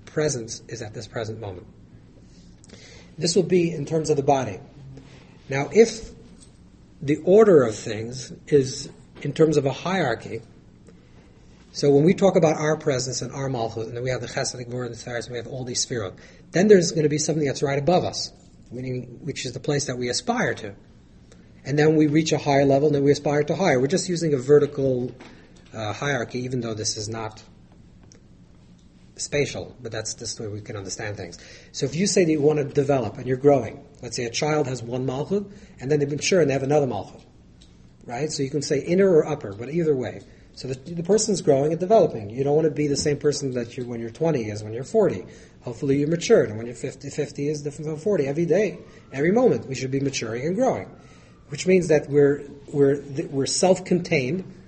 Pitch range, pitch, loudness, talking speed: 120-155 Hz, 140 Hz, -23 LUFS, 215 wpm